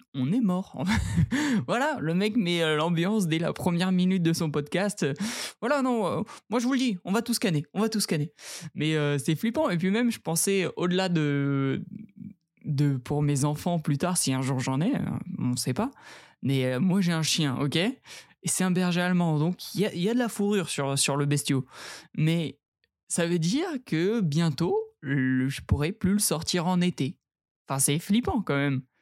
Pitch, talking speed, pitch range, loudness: 175 Hz, 205 wpm, 145-205 Hz, -27 LUFS